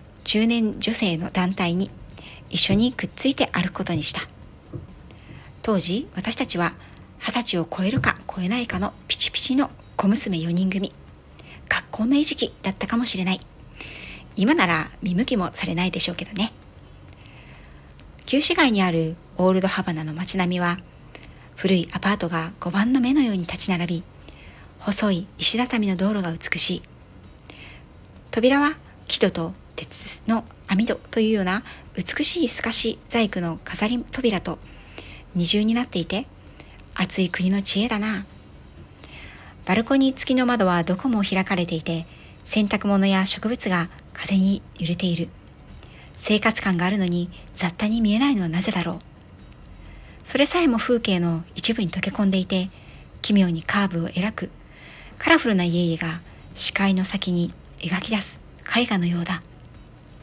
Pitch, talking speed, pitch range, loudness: 190 Hz, 280 characters per minute, 170-220 Hz, -22 LUFS